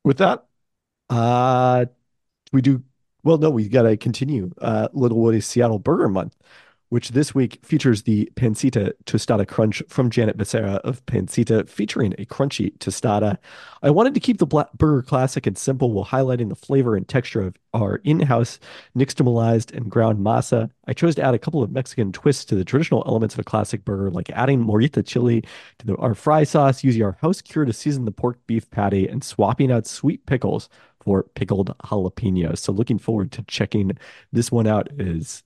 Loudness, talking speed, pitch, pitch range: -21 LUFS, 185 wpm, 120 Hz, 105-135 Hz